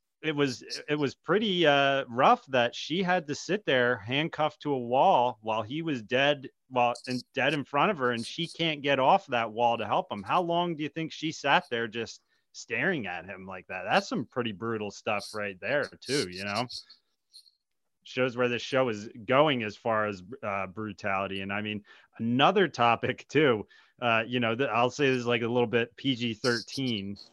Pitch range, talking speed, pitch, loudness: 115-145 Hz, 205 wpm, 120 Hz, -28 LUFS